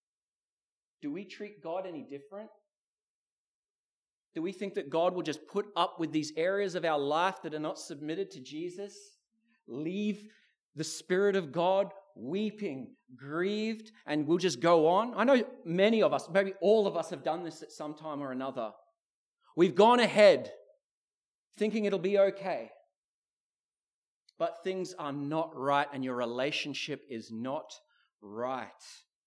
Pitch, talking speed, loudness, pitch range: 180 Hz, 150 wpm, -31 LUFS, 155-205 Hz